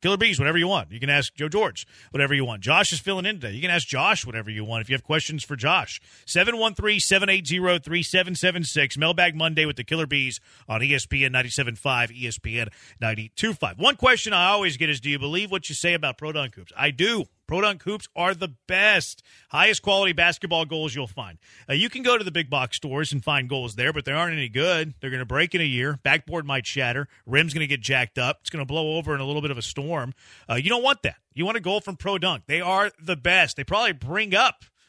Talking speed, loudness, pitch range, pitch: 235 wpm, -23 LUFS, 135-180 Hz, 155 Hz